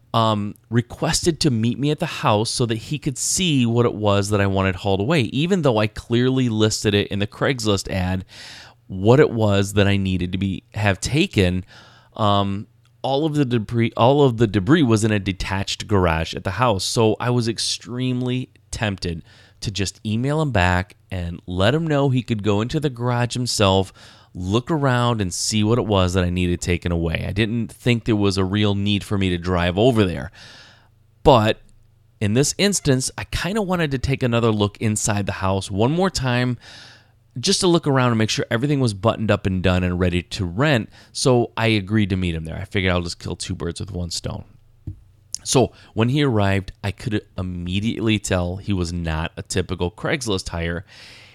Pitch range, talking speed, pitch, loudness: 95-120 Hz, 200 wpm, 110 Hz, -20 LUFS